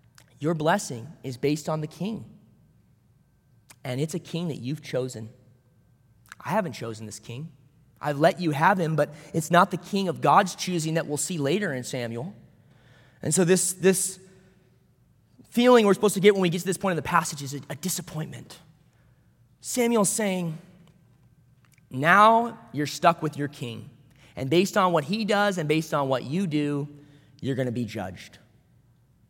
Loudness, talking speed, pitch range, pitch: -25 LUFS, 175 wpm, 130-180 Hz, 150 Hz